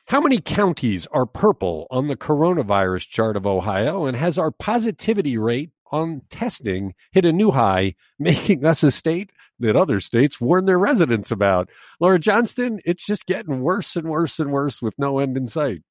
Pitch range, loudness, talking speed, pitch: 115-185 Hz, -20 LUFS, 180 wpm, 155 Hz